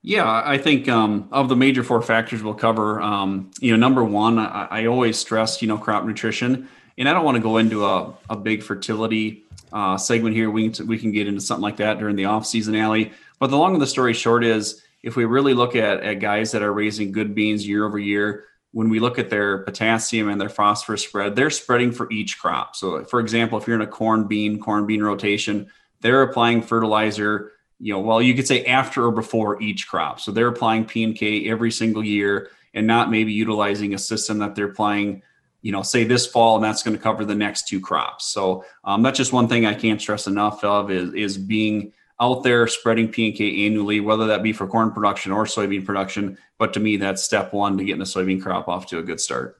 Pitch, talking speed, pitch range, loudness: 110 Hz, 235 wpm, 105-115 Hz, -20 LUFS